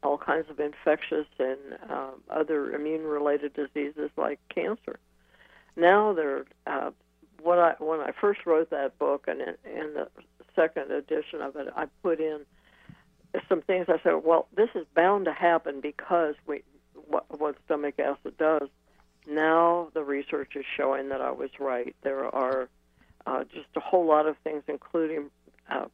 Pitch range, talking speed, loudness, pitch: 145-170 Hz, 160 wpm, -28 LUFS, 155 Hz